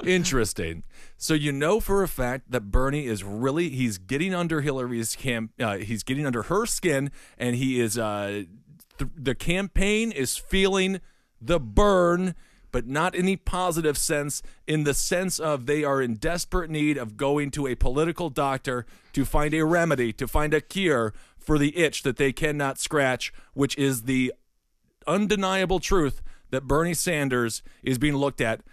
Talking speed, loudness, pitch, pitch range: 170 wpm, -25 LUFS, 140 Hz, 125-170 Hz